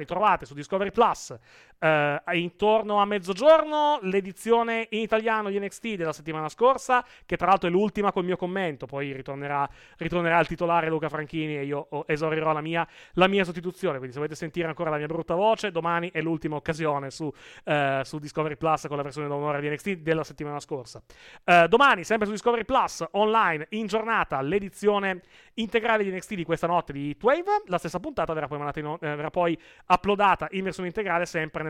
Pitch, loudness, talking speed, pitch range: 170 Hz, -26 LUFS, 190 wpm, 155-205 Hz